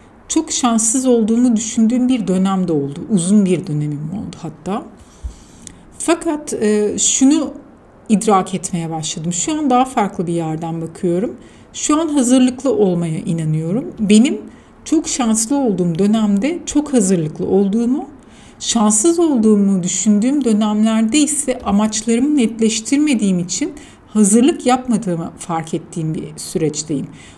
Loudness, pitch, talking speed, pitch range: -16 LUFS, 215 Hz, 110 wpm, 185-260 Hz